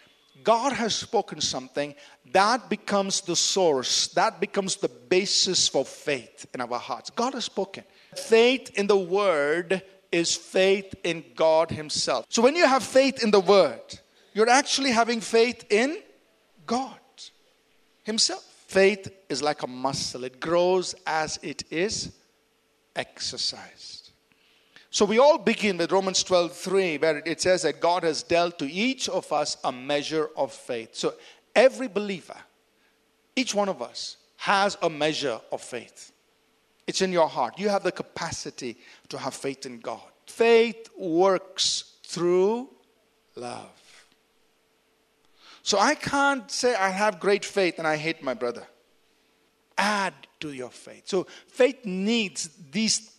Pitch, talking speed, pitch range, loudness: 190 Hz, 145 wpm, 170-225 Hz, -25 LUFS